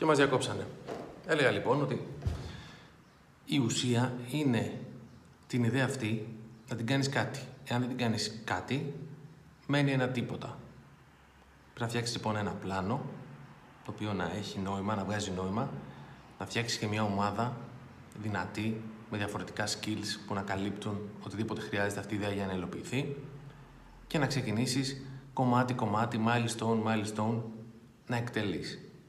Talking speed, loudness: 135 wpm, -33 LUFS